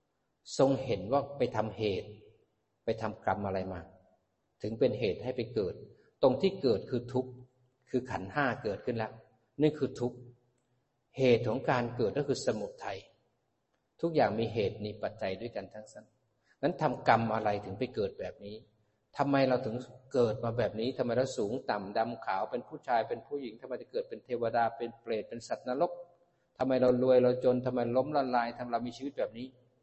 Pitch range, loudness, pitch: 110-130 Hz, -32 LUFS, 125 Hz